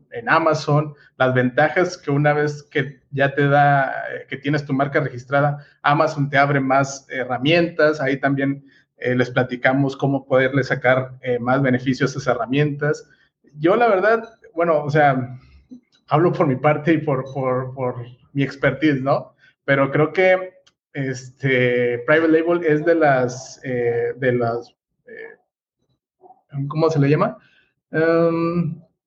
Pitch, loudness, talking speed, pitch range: 140 Hz, -19 LUFS, 145 wpm, 130-155 Hz